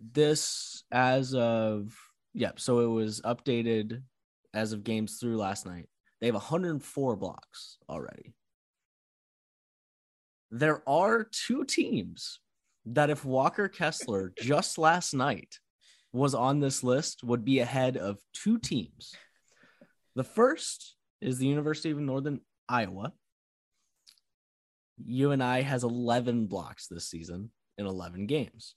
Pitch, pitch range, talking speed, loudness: 125 Hz, 110-145 Hz, 120 wpm, -30 LUFS